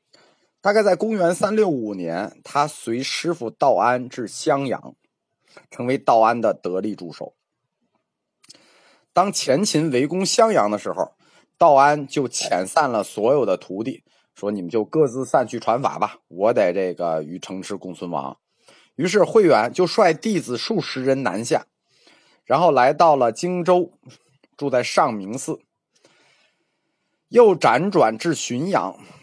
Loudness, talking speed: -20 LUFS, 205 characters per minute